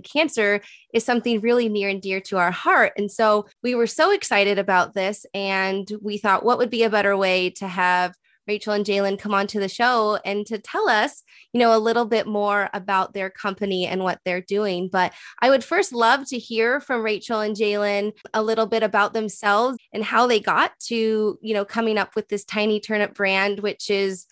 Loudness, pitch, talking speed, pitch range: -21 LUFS, 210 Hz, 210 wpm, 195-225 Hz